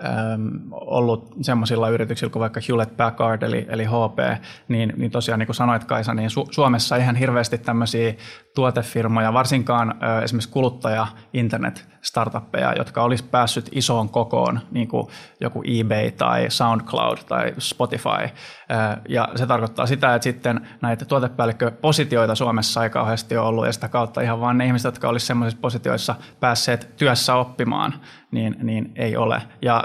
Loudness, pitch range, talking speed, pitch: -21 LUFS, 115-125 Hz, 150 wpm, 115 Hz